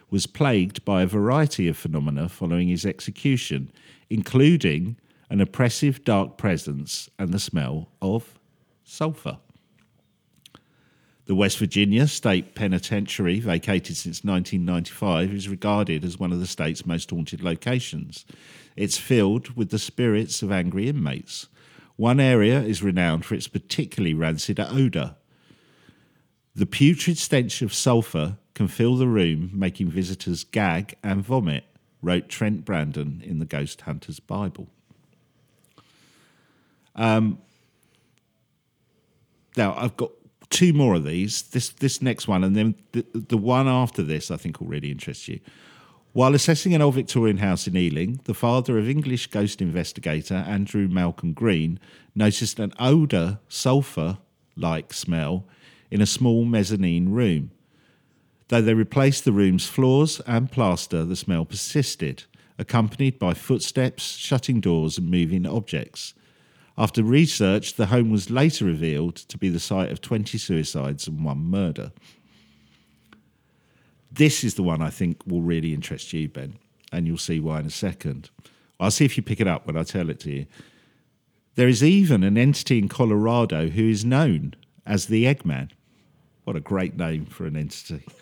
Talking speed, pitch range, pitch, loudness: 150 wpm, 90-125 Hz, 105 Hz, -23 LUFS